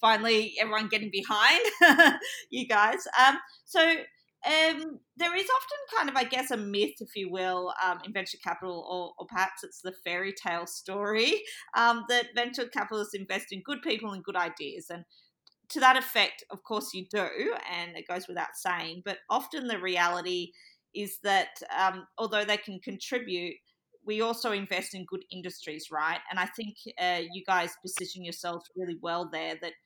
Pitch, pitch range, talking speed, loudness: 195 Hz, 180-235 Hz, 175 wpm, -28 LUFS